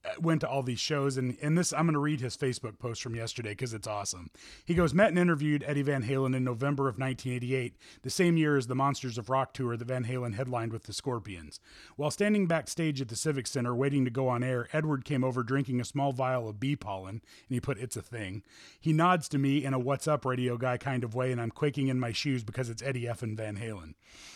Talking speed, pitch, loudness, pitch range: 250 wpm, 130 Hz, -31 LUFS, 120-145 Hz